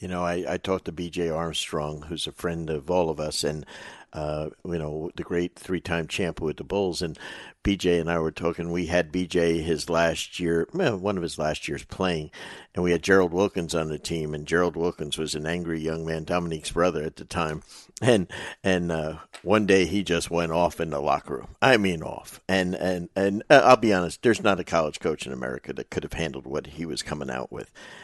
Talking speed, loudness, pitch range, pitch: 225 wpm, -26 LUFS, 80-90 Hz, 85 Hz